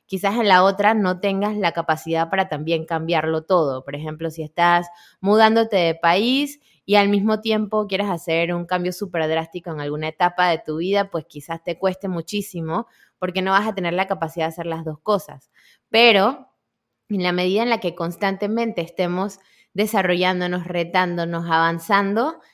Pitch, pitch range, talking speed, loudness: 180 Hz, 165-205 Hz, 170 wpm, -21 LUFS